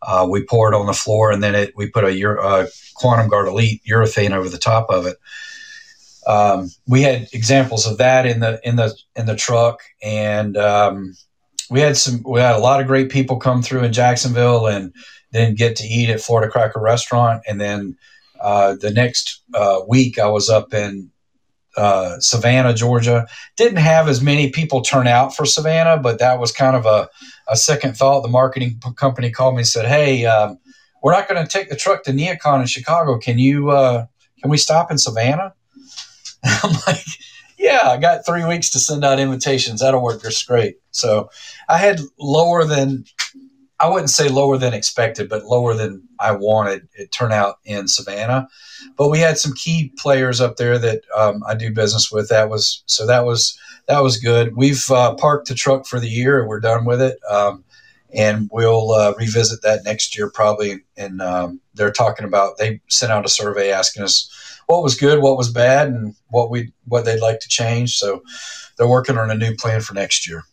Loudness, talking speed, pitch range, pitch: -16 LUFS, 200 wpm, 110-135 Hz, 120 Hz